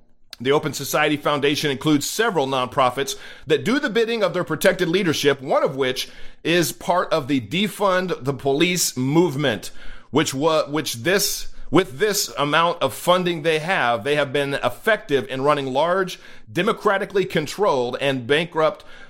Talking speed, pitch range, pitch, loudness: 150 wpm, 140-185 Hz, 155 Hz, -21 LUFS